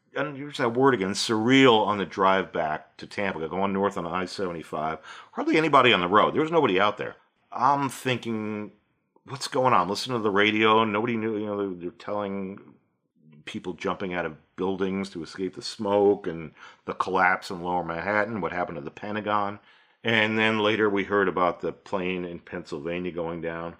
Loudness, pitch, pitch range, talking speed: -25 LUFS, 100 Hz, 90-110 Hz, 185 wpm